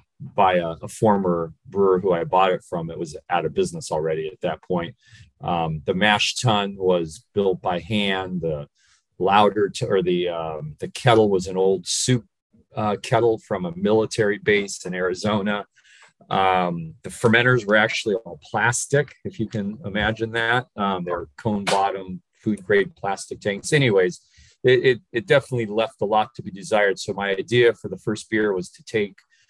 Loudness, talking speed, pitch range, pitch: -22 LUFS, 180 wpm, 95-115 Hz, 105 Hz